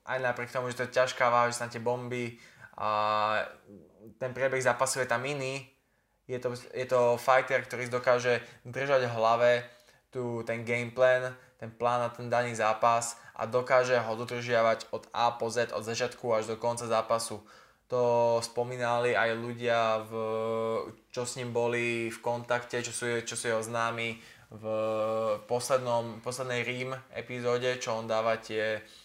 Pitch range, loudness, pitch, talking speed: 115-125 Hz, -30 LUFS, 120 Hz, 165 wpm